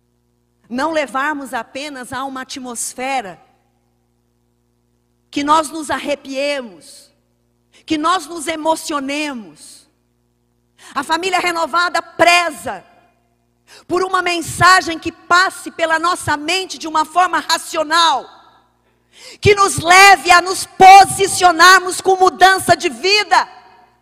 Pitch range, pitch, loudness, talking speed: 250-355 Hz, 315 Hz, -13 LUFS, 100 wpm